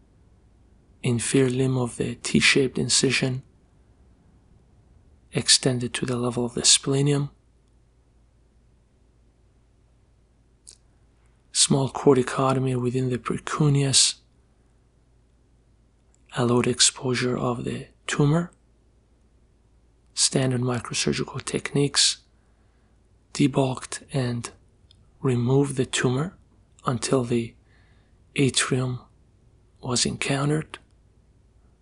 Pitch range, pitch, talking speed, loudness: 115-135 Hz, 125 Hz, 70 wpm, -23 LUFS